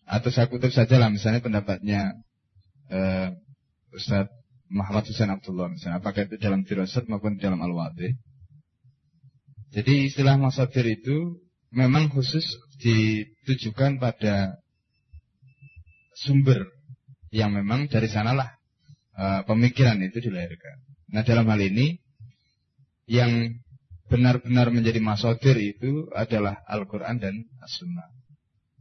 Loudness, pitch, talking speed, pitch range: -24 LUFS, 115 Hz, 110 wpm, 105-130 Hz